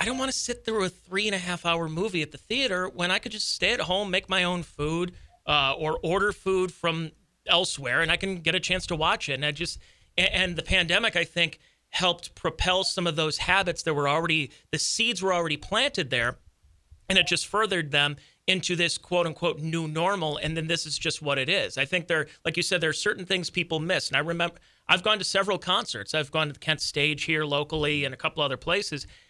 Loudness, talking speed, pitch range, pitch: -26 LUFS, 240 wpm, 155-185 Hz, 170 Hz